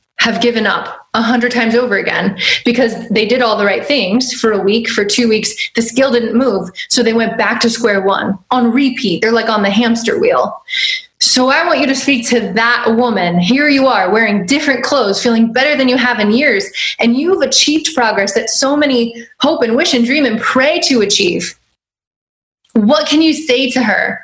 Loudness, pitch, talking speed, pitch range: -12 LUFS, 240 Hz, 210 wpm, 225-270 Hz